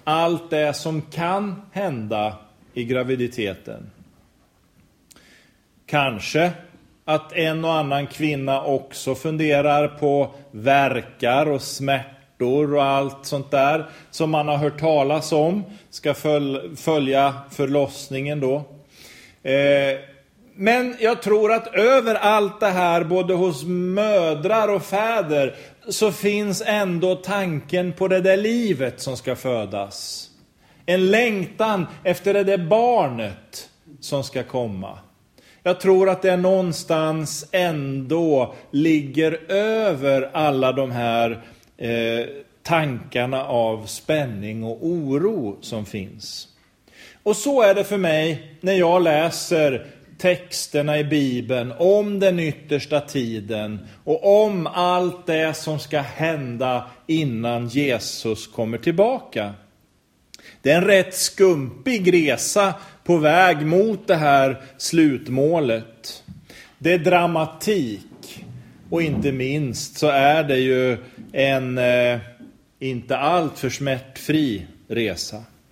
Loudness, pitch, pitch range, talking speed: -21 LUFS, 150 Hz, 130-180 Hz, 110 wpm